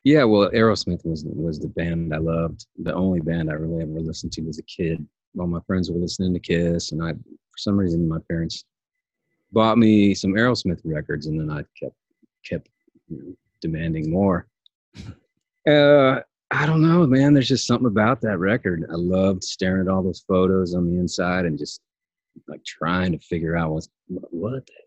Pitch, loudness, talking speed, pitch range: 90 Hz, -22 LUFS, 195 wpm, 80-110 Hz